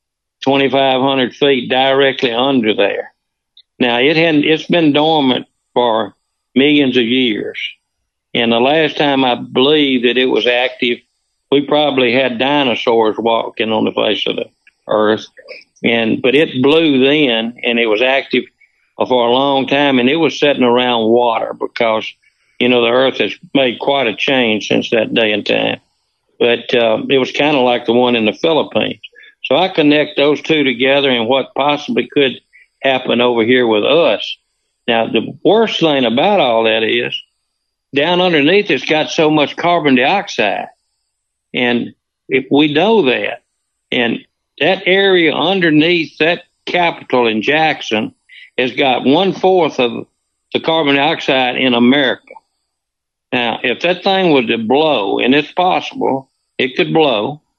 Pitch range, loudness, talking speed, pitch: 125-160 Hz, -13 LUFS, 155 wpm, 135 Hz